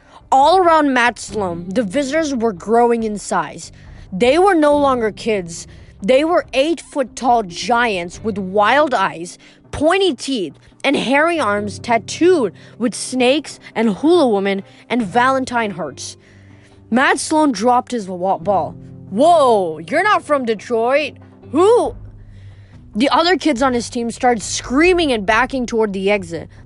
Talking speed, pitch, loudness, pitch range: 140 wpm, 235 Hz, -16 LUFS, 195-280 Hz